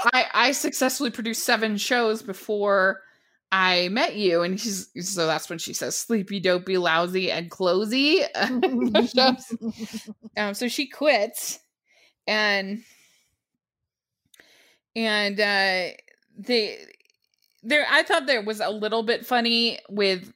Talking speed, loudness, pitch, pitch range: 120 wpm, -23 LUFS, 220 Hz, 195-245 Hz